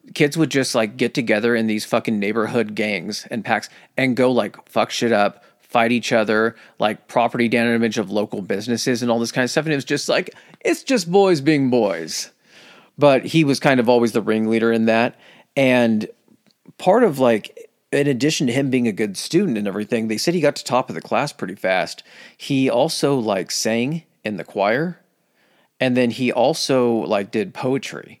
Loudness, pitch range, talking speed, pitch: -19 LUFS, 115-145 Hz, 200 wpm, 125 Hz